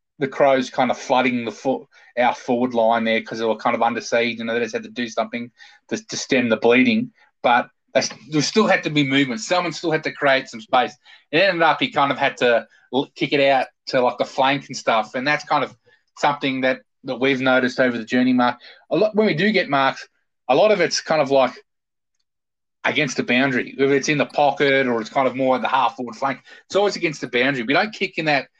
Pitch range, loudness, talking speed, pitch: 120-150 Hz, -20 LUFS, 245 wpm, 135 Hz